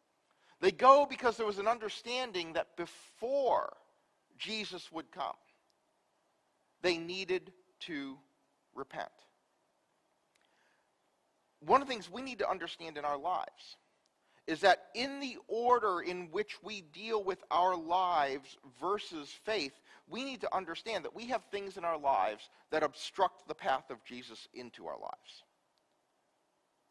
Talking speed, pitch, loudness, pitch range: 135 wpm, 185 Hz, -34 LUFS, 160-225 Hz